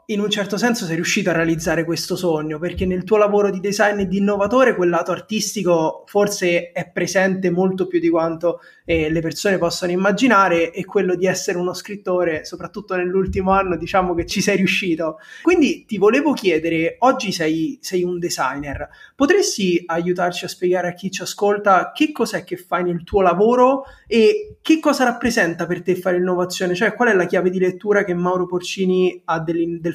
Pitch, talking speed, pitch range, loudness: 185 Hz, 185 wpm, 175-205 Hz, -19 LUFS